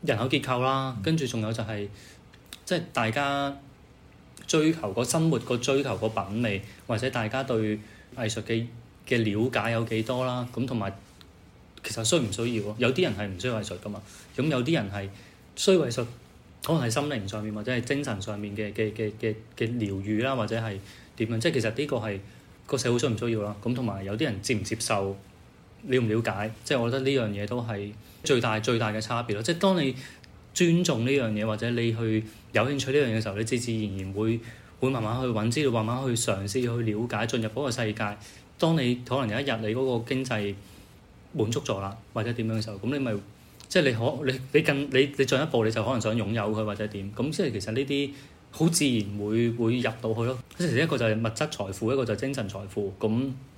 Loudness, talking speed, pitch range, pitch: -28 LUFS, 310 characters per minute, 105-130 Hz, 115 Hz